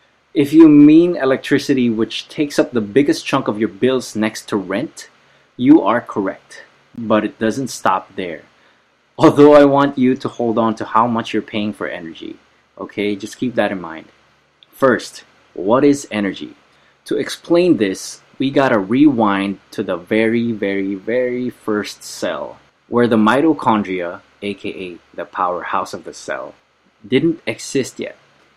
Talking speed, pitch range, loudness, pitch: 155 wpm, 105-140 Hz, -16 LUFS, 115 Hz